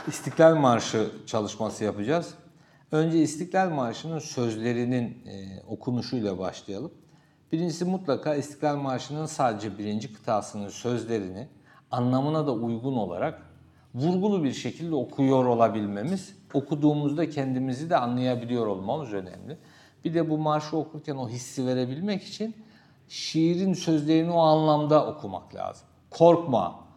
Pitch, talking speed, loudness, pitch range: 145 Hz, 110 wpm, -27 LUFS, 120-160 Hz